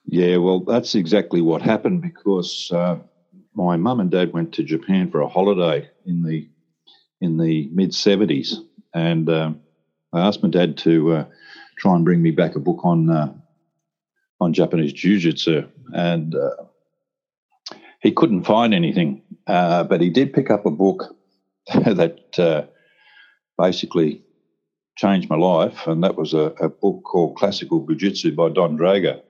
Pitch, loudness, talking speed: 90 Hz, -19 LUFS, 155 wpm